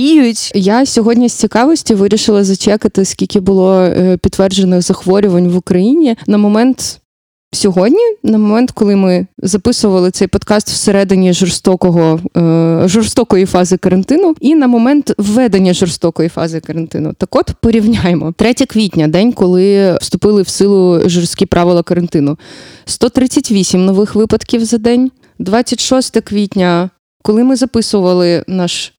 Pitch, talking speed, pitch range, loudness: 200 Hz, 120 wpm, 180-230 Hz, -11 LUFS